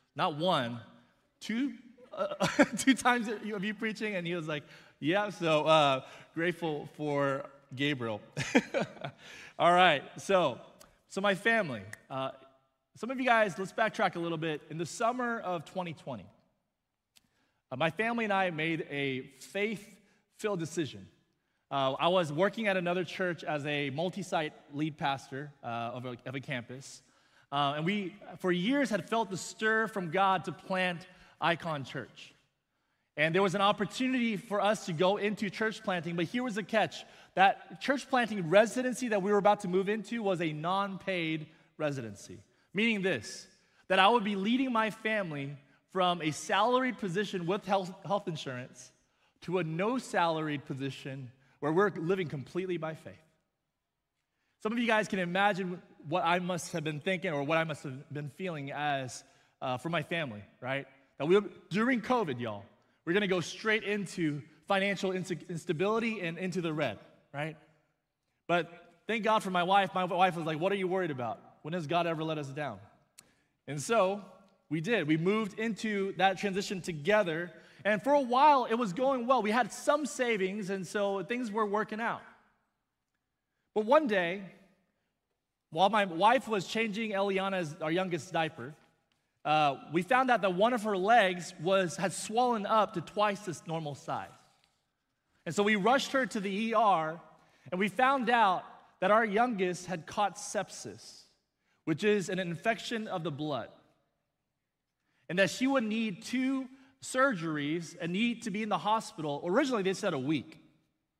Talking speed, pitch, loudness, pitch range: 170 wpm, 185 Hz, -31 LUFS, 155-215 Hz